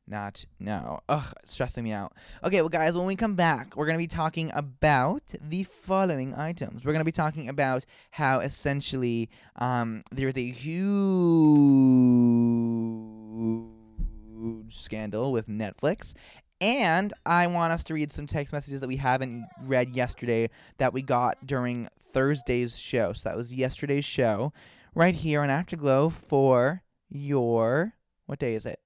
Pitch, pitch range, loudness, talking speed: 135 Hz, 115-155 Hz, -27 LUFS, 150 wpm